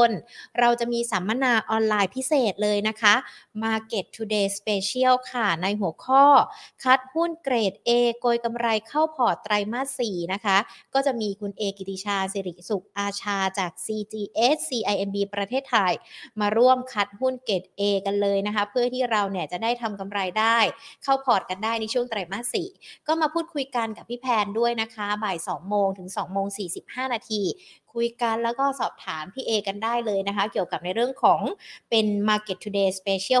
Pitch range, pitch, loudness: 200-245 Hz, 220 Hz, -25 LUFS